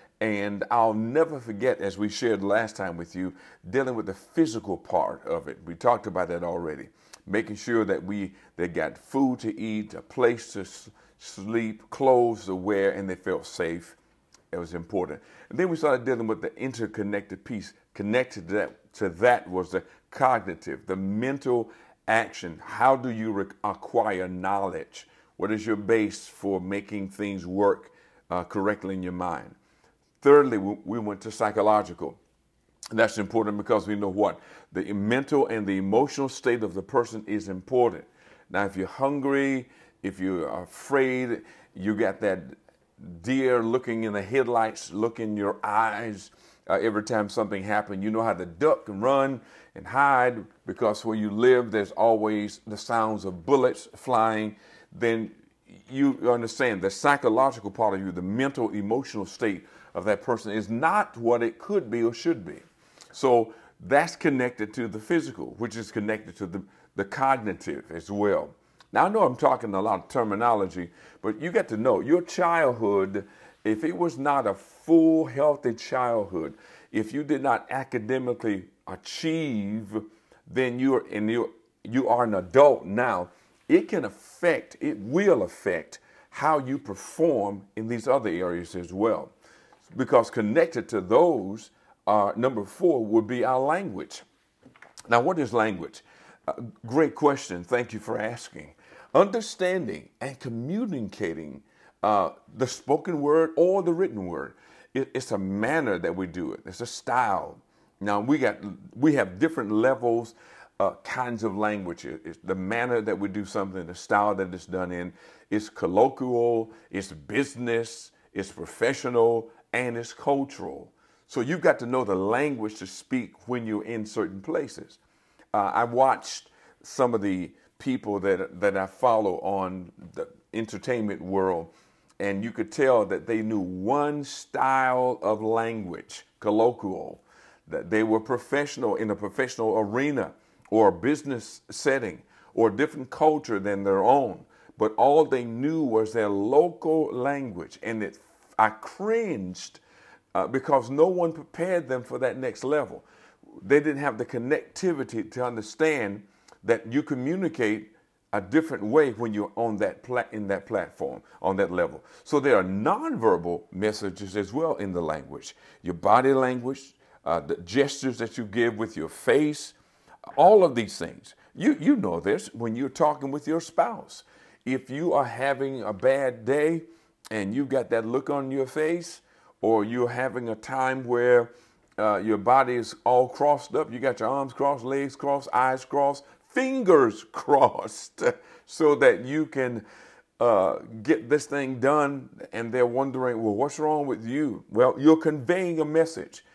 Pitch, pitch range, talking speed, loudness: 115 Hz, 105-135 Hz, 160 wpm, -26 LUFS